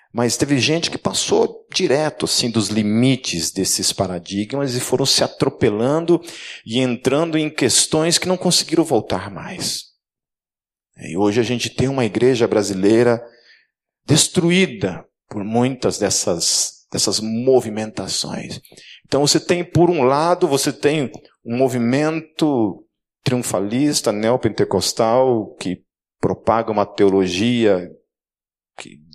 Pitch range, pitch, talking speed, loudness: 110-155 Hz, 125 Hz, 115 wpm, -18 LUFS